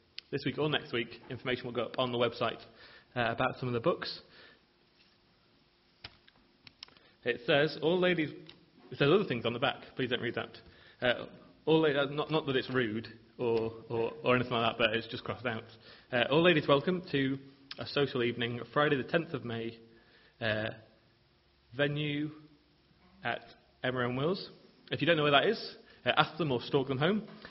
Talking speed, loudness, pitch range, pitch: 185 wpm, -32 LUFS, 115-150 Hz, 125 Hz